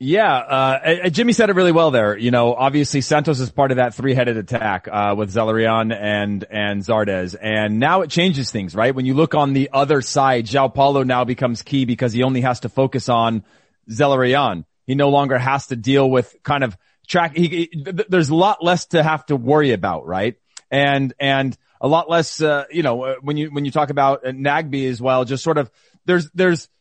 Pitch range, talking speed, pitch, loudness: 120-150 Hz, 210 wpm, 135 Hz, -18 LUFS